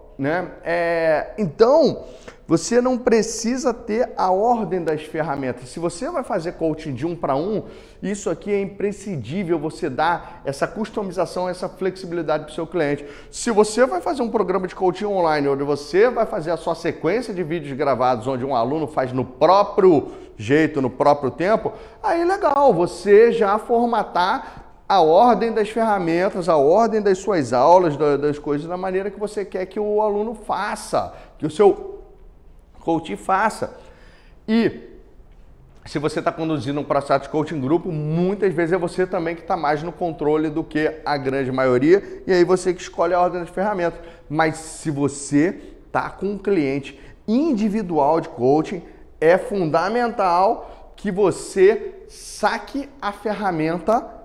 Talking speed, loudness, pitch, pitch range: 160 wpm, -20 LUFS, 180 Hz, 155-215 Hz